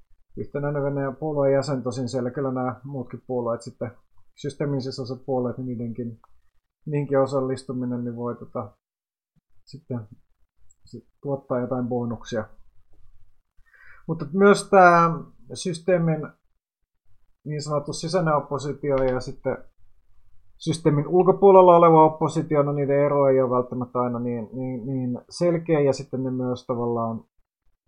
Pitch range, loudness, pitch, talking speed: 120-145 Hz, -23 LUFS, 130 Hz, 120 wpm